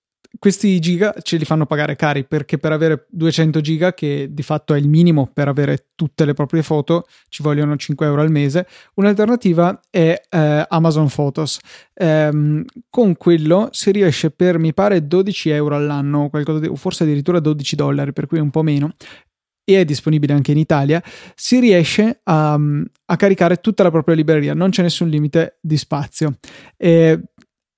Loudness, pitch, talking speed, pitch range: -16 LUFS, 160 Hz, 170 wpm, 150-180 Hz